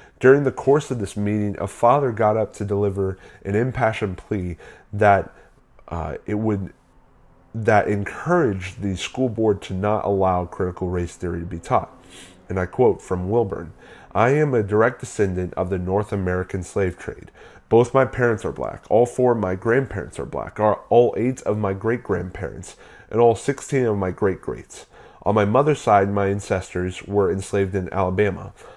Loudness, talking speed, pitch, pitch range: -21 LUFS, 175 wpm, 105 Hz, 95-115 Hz